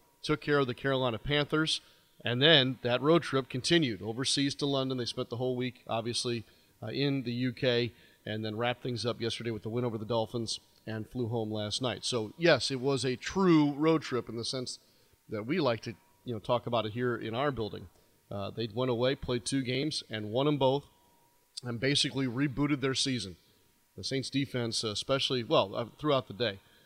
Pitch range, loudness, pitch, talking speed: 115-140 Hz, -31 LUFS, 125 Hz, 205 wpm